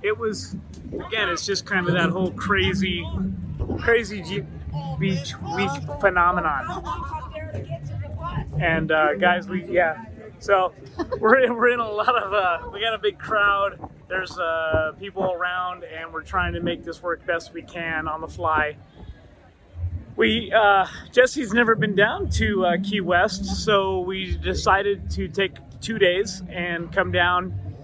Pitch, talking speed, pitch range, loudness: 180 Hz, 155 wpm, 150-200 Hz, -23 LUFS